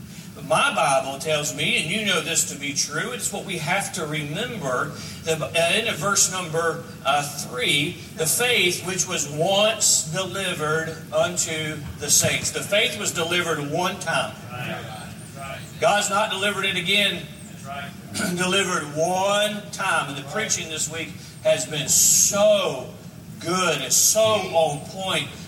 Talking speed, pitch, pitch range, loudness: 135 wpm, 170 Hz, 155-195 Hz, -21 LUFS